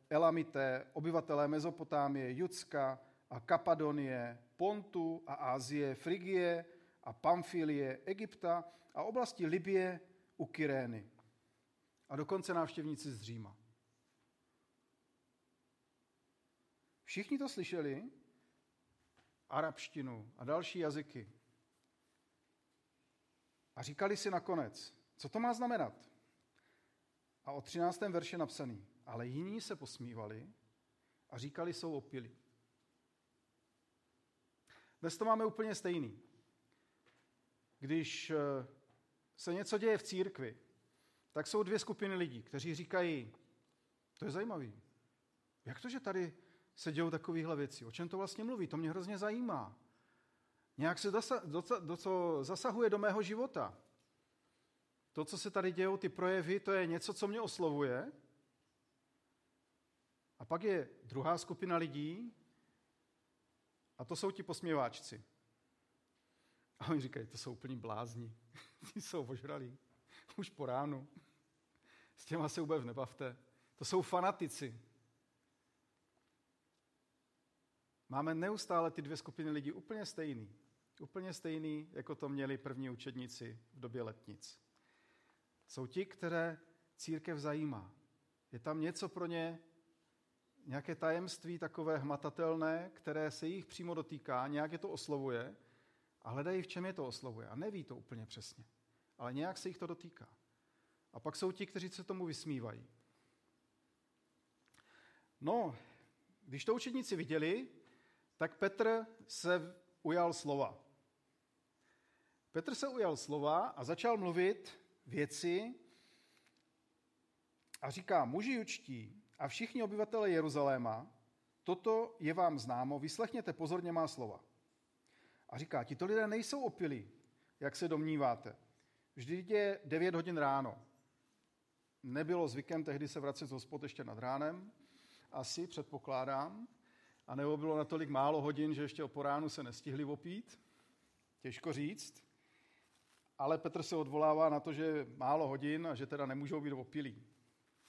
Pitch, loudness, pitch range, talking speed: 155 Hz, -41 LUFS, 135-180 Hz, 120 wpm